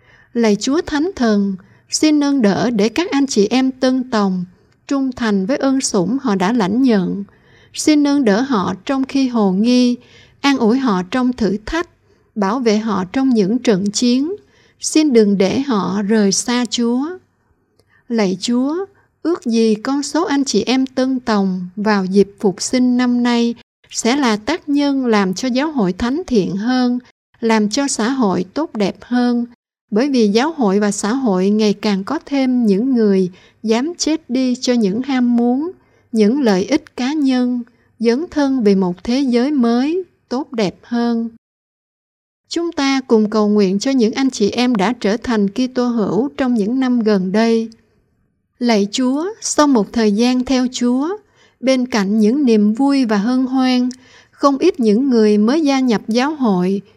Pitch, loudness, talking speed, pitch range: 240 Hz, -16 LUFS, 175 wpm, 210-265 Hz